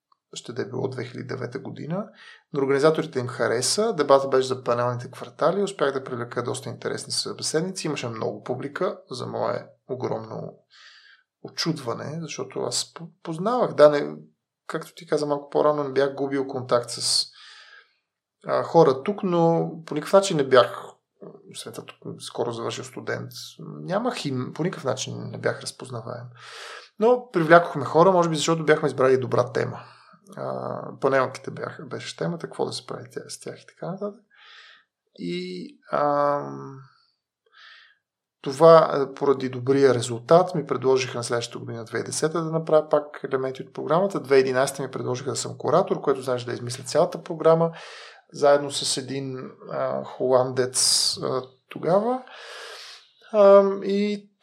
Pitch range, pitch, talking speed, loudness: 125-165 Hz, 140 Hz, 140 wpm, -23 LUFS